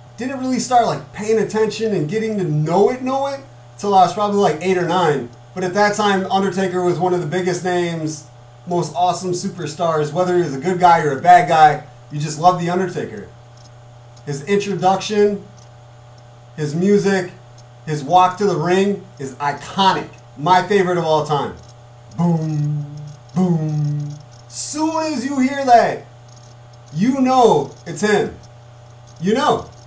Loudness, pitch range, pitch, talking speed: -17 LUFS, 135-195 Hz, 175 Hz, 160 wpm